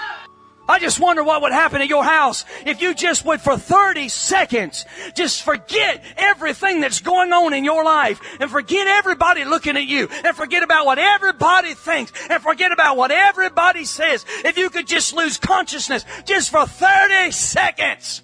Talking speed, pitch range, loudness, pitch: 175 wpm, 295-365 Hz, -16 LUFS, 330 Hz